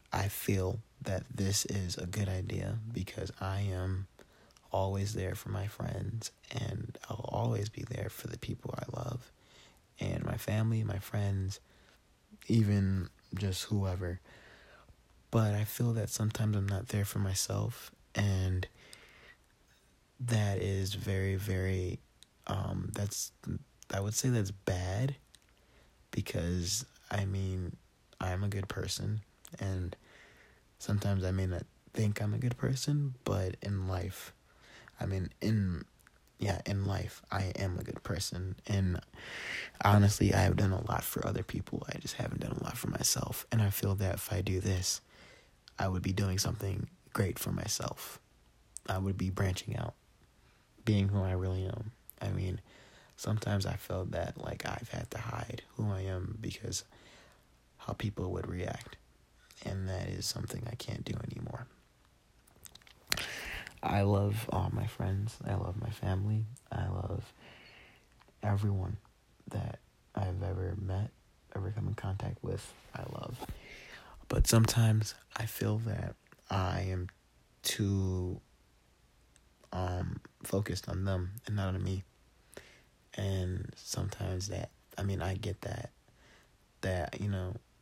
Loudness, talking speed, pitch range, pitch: -35 LUFS, 145 wpm, 95-110 Hz, 100 Hz